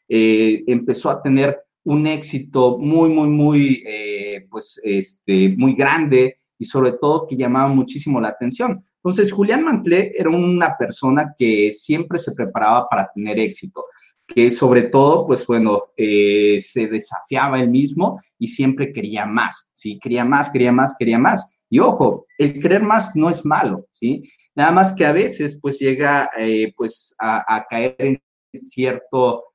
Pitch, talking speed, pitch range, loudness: 135 Hz, 160 wpm, 115-150 Hz, -17 LUFS